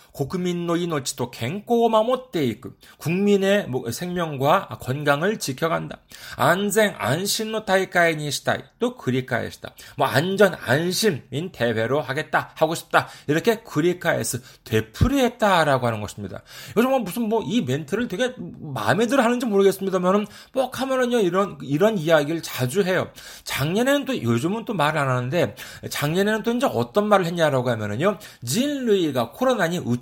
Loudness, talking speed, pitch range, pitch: -22 LUFS, 340 characters per minute, 135-215 Hz, 175 Hz